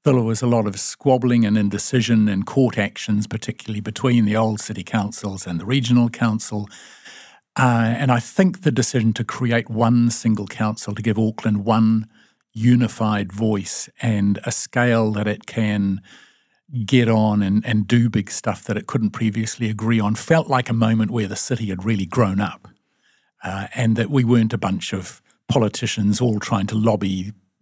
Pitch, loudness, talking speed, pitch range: 110 Hz, -20 LUFS, 175 wpm, 105-120 Hz